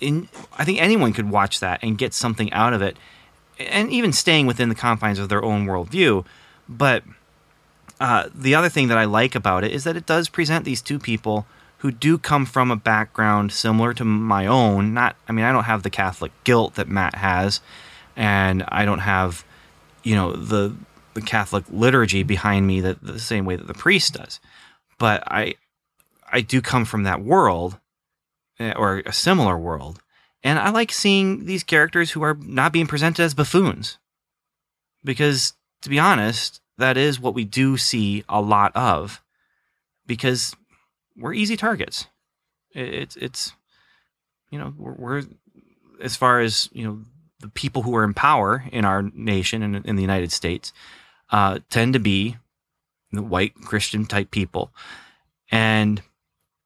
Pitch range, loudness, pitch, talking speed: 100-130 Hz, -20 LUFS, 110 Hz, 170 wpm